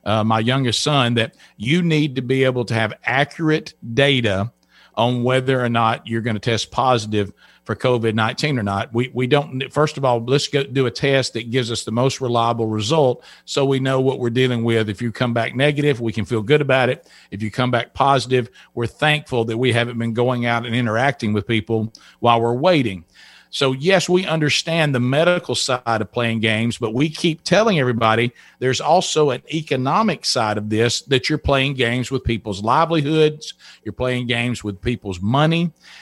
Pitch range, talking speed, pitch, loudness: 115-140 Hz, 200 wpm, 125 Hz, -19 LUFS